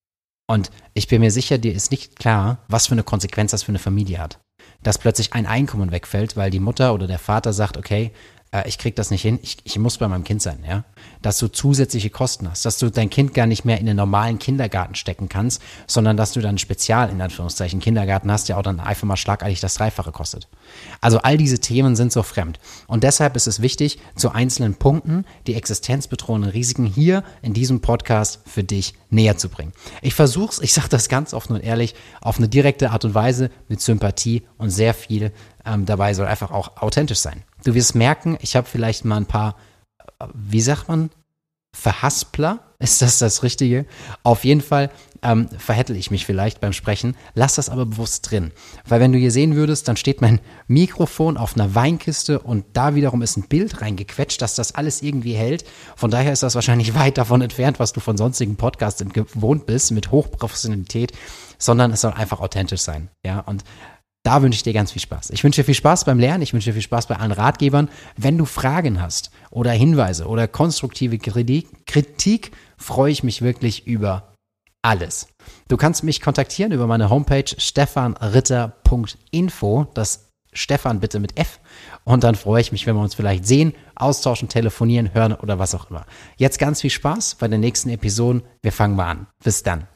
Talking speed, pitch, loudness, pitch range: 200 wpm, 115 Hz, -19 LUFS, 105-130 Hz